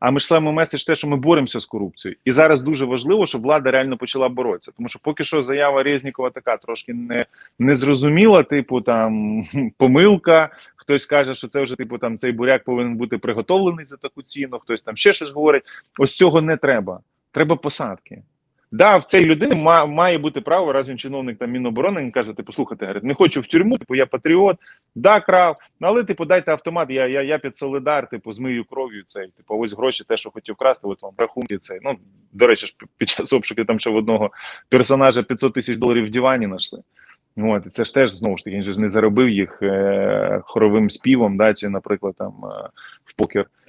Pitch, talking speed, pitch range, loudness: 130 Hz, 200 wpm, 115-150 Hz, -18 LUFS